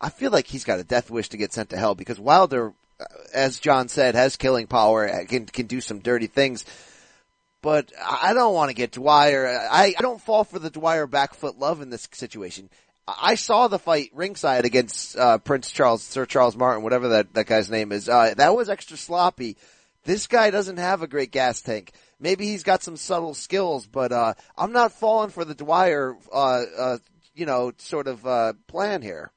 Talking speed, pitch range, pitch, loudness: 205 wpm, 120-175 Hz, 135 Hz, -22 LUFS